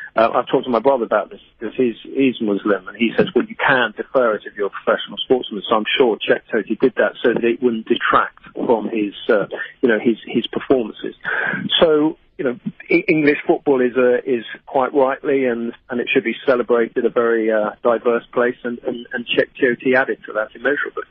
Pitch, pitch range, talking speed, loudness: 120 Hz, 115-135 Hz, 215 wpm, -18 LUFS